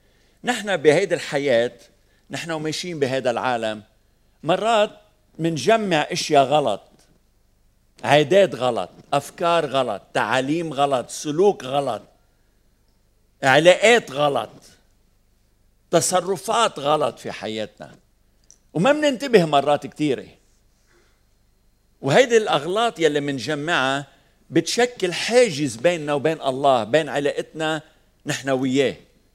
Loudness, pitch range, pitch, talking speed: -20 LUFS, 115-170 Hz, 145 Hz, 85 wpm